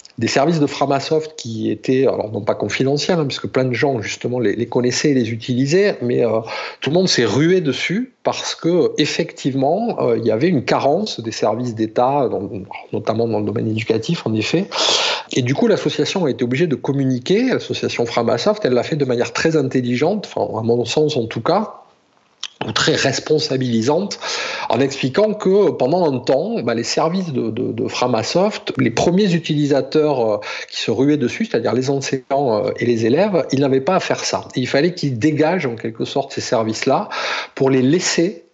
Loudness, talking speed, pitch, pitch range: -18 LUFS, 190 wpm, 135 Hz, 120-160 Hz